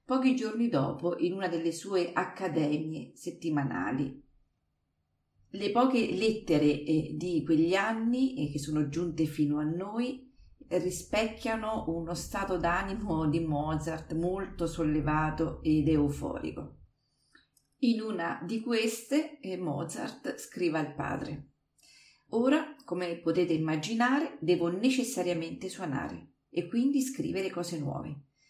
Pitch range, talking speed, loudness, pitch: 155-220 Hz, 105 wpm, -31 LUFS, 175 Hz